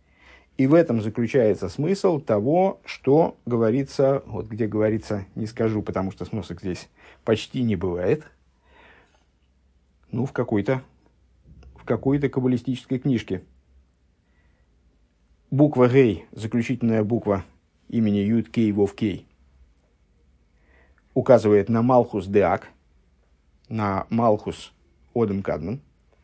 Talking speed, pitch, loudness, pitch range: 105 wpm, 100 Hz, -23 LUFS, 70-115 Hz